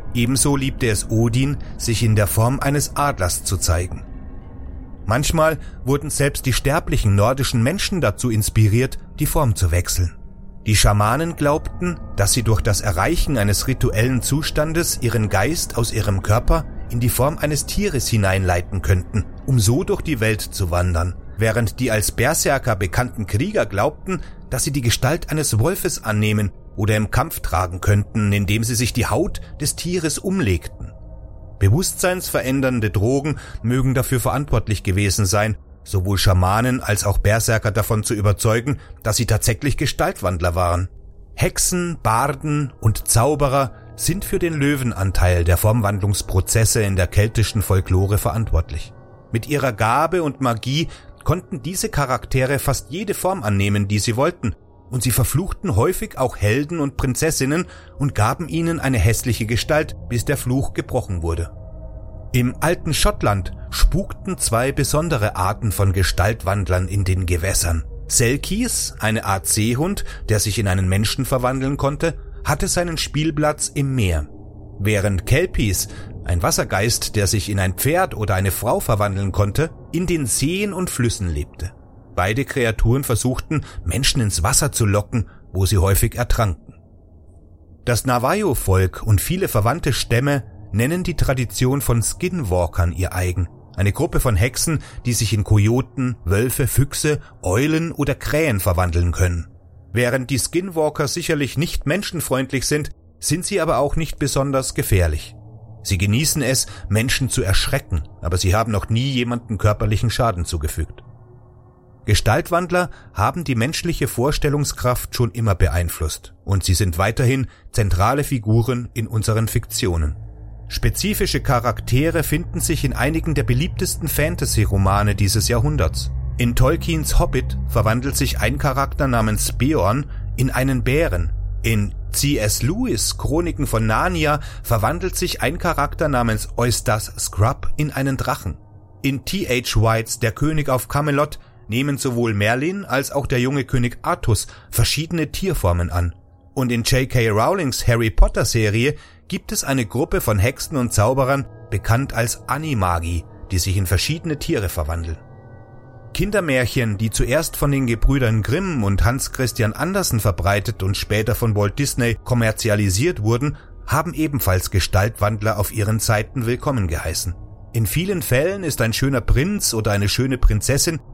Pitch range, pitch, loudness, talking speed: 100-135 Hz, 115 Hz, -20 LUFS, 140 wpm